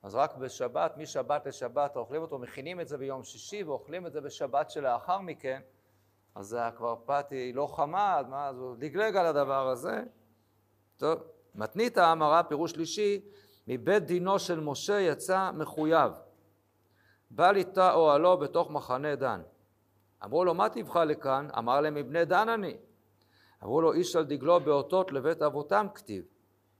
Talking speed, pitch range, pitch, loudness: 145 wpm, 130-175 Hz, 150 Hz, -30 LUFS